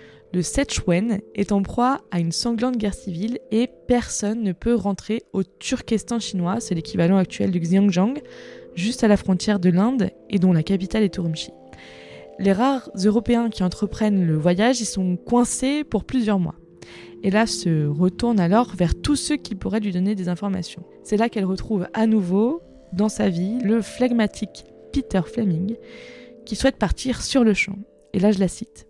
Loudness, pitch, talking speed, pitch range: -22 LUFS, 210 Hz, 180 wpm, 185-235 Hz